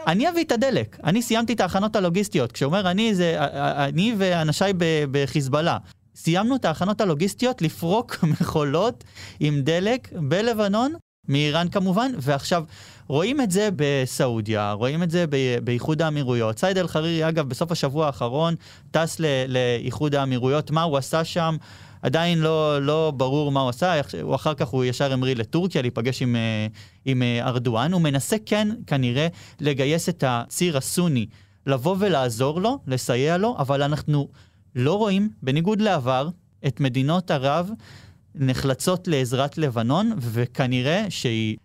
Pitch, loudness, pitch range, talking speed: 150 Hz, -23 LUFS, 130-175 Hz, 135 wpm